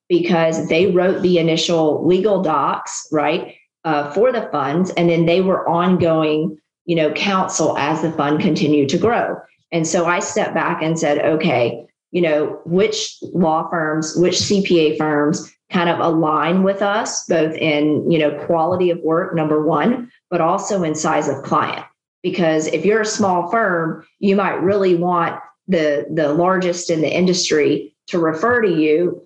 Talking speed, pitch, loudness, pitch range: 170 wpm, 170 Hz, -17 LUFS, 155-185 Hz